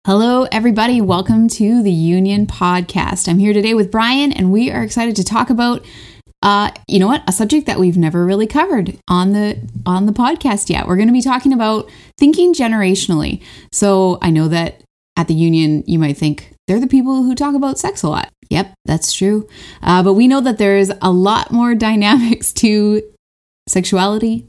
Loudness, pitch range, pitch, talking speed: -14 LUFS, 185-235 Hz, 210 Hz, 190 wpm